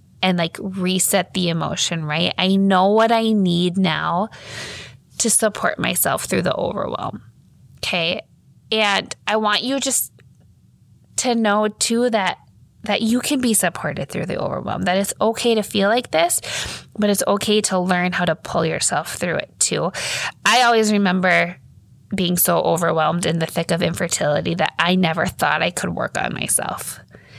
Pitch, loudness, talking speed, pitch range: 195 Hz, -19 LUFS, 165 wpm, 175-220 Hz